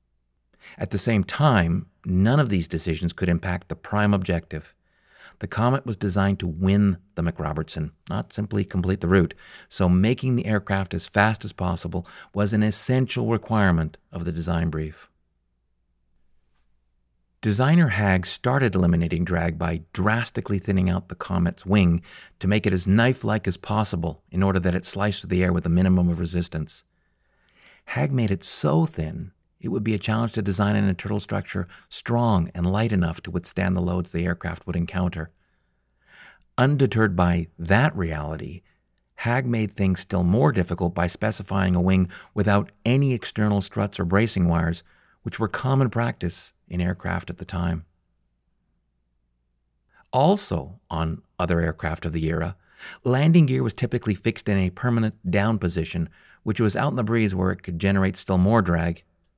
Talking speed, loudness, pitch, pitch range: 165 wpm, -24 LUFS, 90 Hz, 85-105 Hz